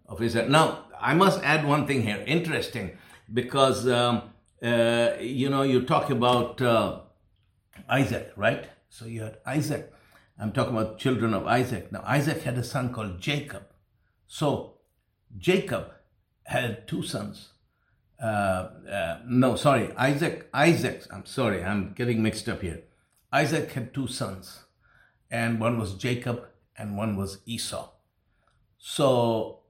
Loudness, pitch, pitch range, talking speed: -26 LUFS, 120 Hz, 105-130 Hz, 135 wpm